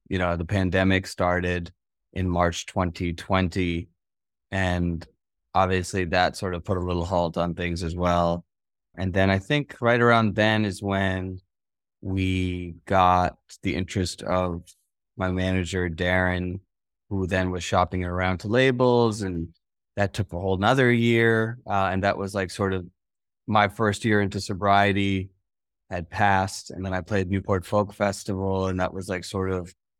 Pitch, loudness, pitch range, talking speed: 95 Hz, -24 LUFS, 90-100 Hz, 160 wpm